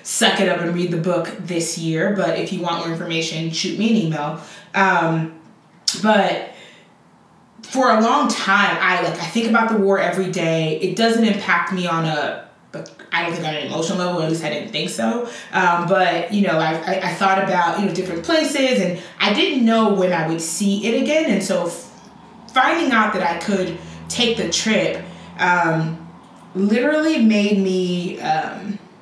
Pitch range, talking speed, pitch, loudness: 170-215 Hz, 190 wpm, 185 Hz, -19 LUFS